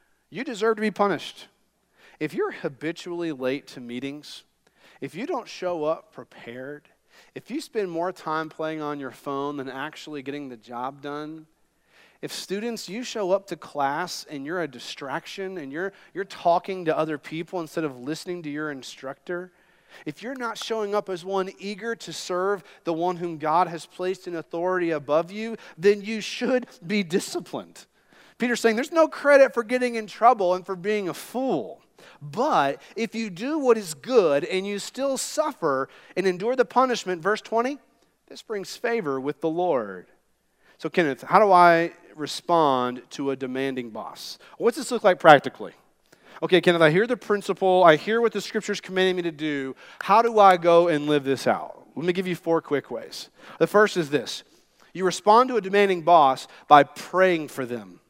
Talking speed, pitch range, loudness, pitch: 185 wpm, 150-215 Hz, -24 LUFS, 180 Hz